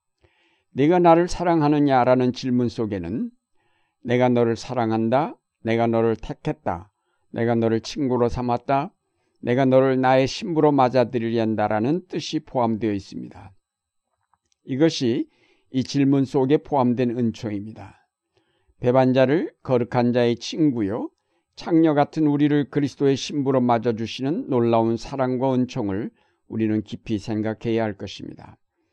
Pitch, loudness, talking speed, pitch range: 125 Hz, -22 LUFS, 290 characters per minute, 115-145 Hz